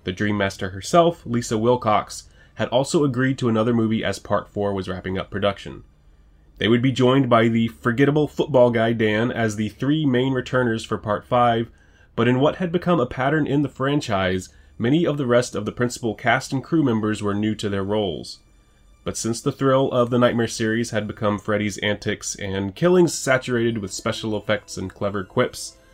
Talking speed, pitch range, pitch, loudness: 195 wpm, 100-125 Hz, 115 Hz, -21 LUFS